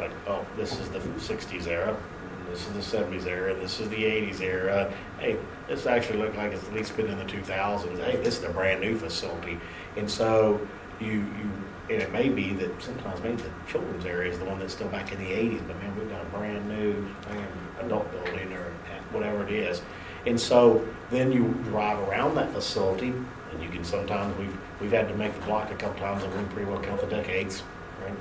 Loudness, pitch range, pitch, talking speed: -29 LUFS, 95-105 Hz, 100 Hz, 215 wpm